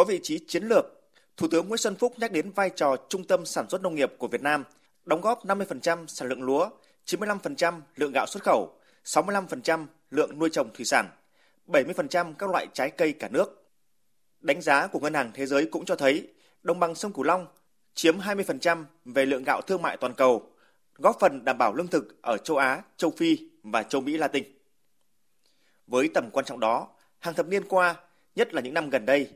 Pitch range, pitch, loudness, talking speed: 155-200 Hz, 175 Hz, -27 LUFS, 205 wpm